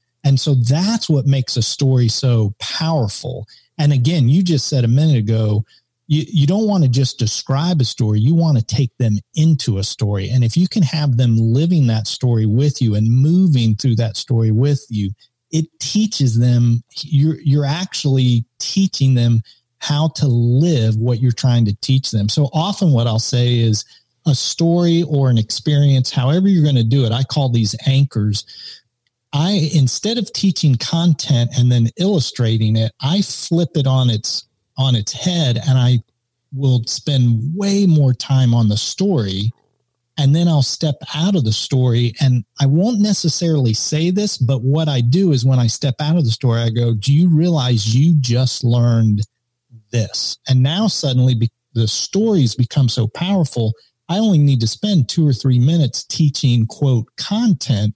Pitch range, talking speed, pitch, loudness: 120-155 Hz, 180 wpm, 130 Hz, -16 LUFS